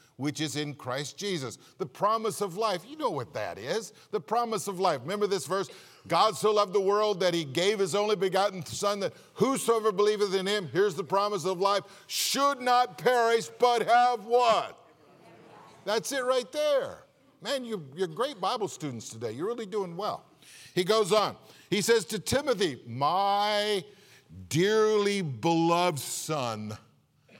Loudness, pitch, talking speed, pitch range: -28 LUFS, 205 Hz, 165 wpm, 175-220 Hz